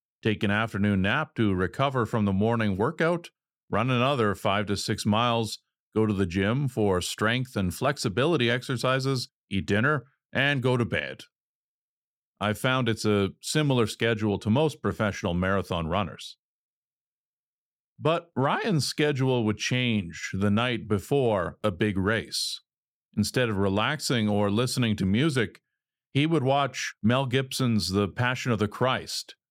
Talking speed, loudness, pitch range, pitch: 140 wpm, -26 LUFS, 105-130 Hz, 115 Hz